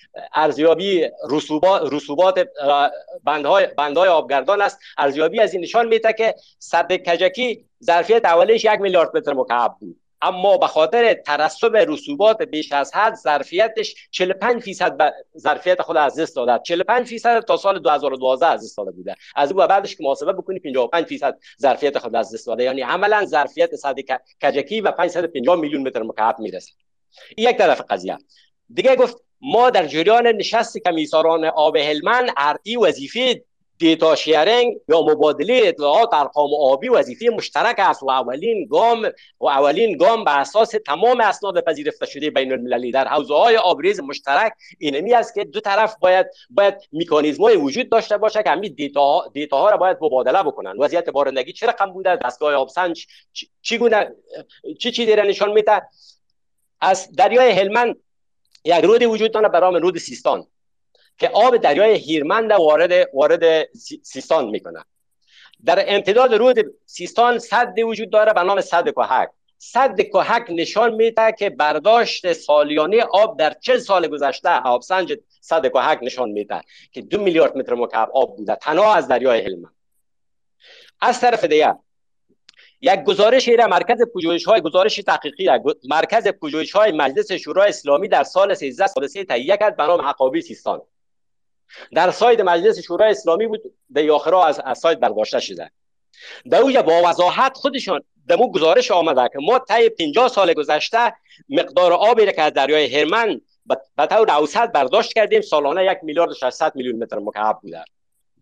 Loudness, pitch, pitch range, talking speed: -17 LUFS, 185 Hz, 155-230 Hz, 155 wpm